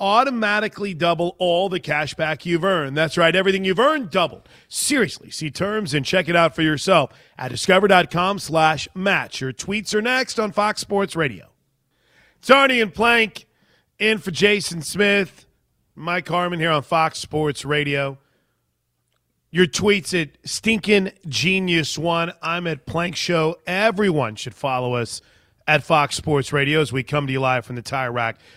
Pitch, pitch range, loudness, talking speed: 170 Hz, 145-195 Hz, -20 LUFS, 165 wpm